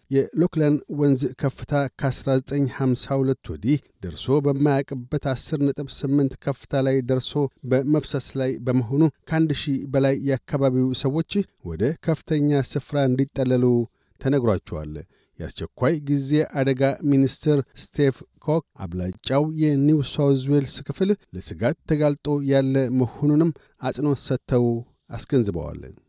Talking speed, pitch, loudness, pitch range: 100 wpm, 135 Hz, -23 LUFS, 130-145 Hz